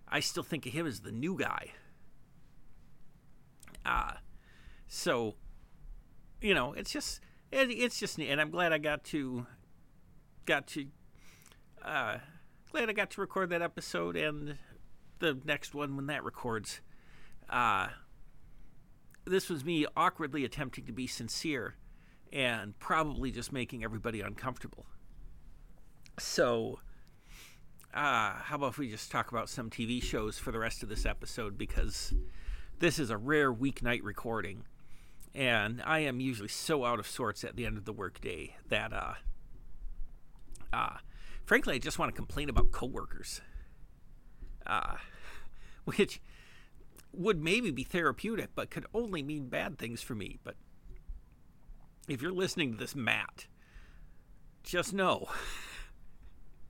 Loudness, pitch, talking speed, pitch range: -35 LUFS, 130 Hz, 135 wpm, 110-155 Hz